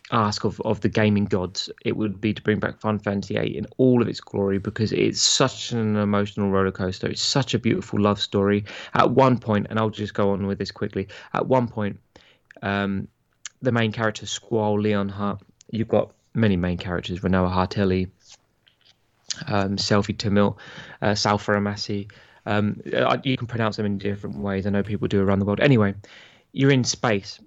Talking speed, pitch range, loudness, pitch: 190 wpm, 100-110 Hz, -23 LUFS, 105 Hz